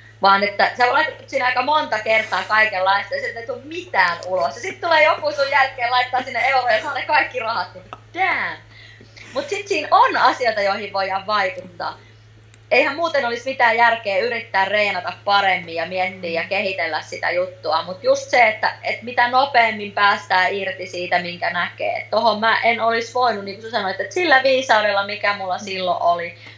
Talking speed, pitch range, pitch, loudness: 175 wpm, 185-260 Hz, 215 Hz, -19 LUFS